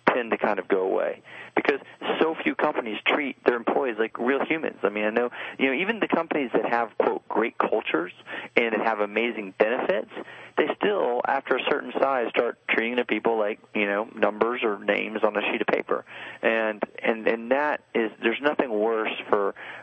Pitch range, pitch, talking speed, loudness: 105-115 Hz, 110 Hz, 195 wpm, -25 LUFS